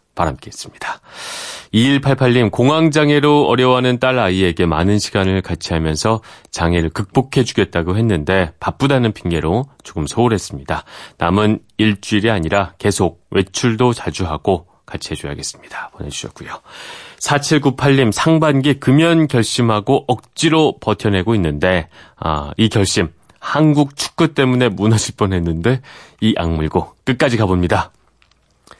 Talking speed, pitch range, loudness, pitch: 295 characters per minute, 90-130 Hz, -16 LUFS, 110 Hz